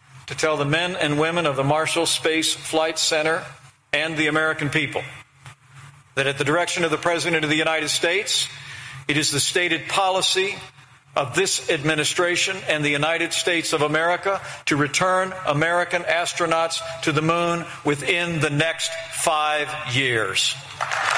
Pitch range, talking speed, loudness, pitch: 145-170 Hz, 150 wpm, -21 LUFS, 155 Hz